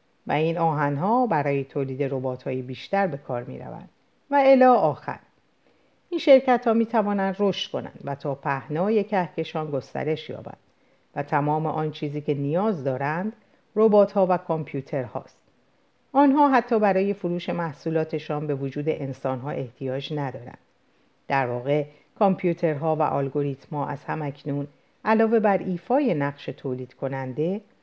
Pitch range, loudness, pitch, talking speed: 140-195 Hz, -24 LUFS, 155 Hz, 145 wpm